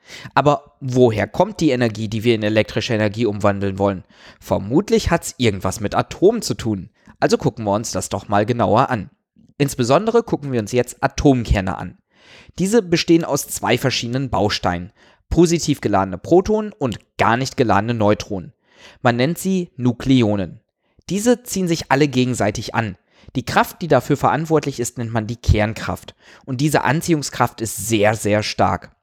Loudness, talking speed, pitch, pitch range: -19 LUFS, 160 wpm, 120 Hz, 105-145 Hz